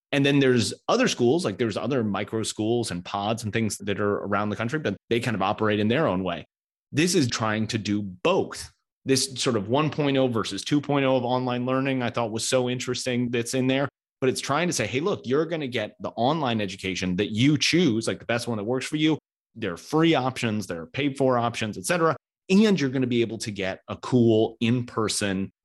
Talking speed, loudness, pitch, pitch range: 230 wpm, -25 LUFS, 120 Hz, 105-135 Hz